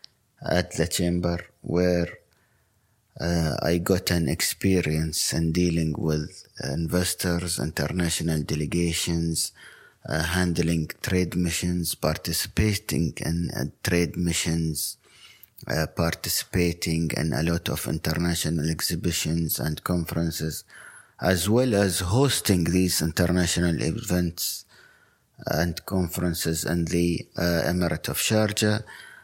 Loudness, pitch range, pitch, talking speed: -25 LUFS, 80-90 Hz, 85 Hz, 100 wpm